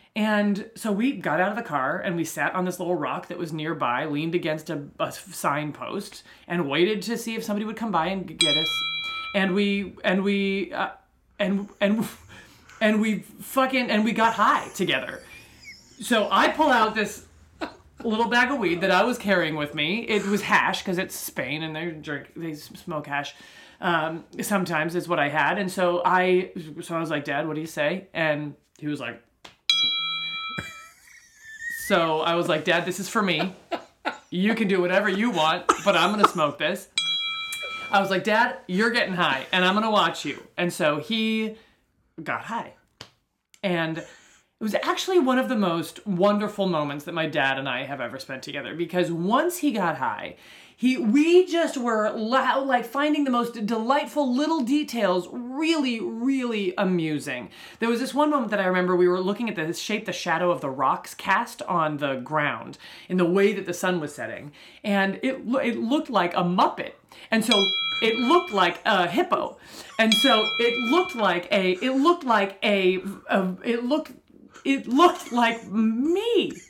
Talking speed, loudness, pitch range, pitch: 185 wpm, -24 LUFS, 175-250 Hz, 205 Hz